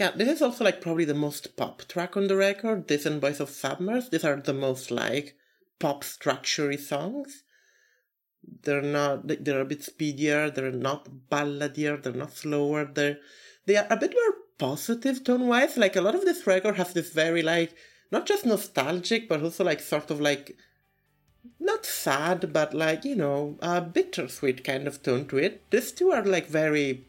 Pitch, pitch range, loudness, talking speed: 155 Hz, 145-200 Hz, -27 LUFS, 185 wpm